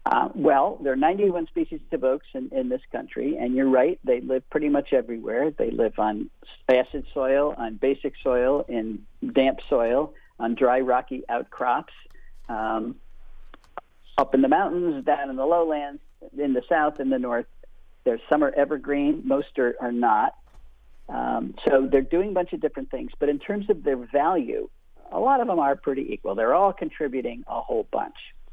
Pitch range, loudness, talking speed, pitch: 125-175 Hz, -24 LUFS, 180 wpm, 140 Hz